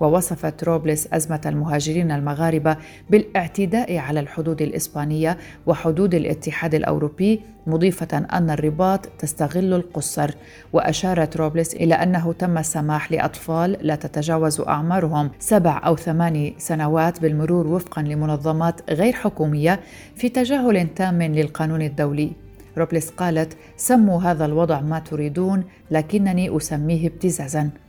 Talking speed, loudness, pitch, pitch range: 110 wpm, -21 LUFS, 160 Hz, 155-175 Hz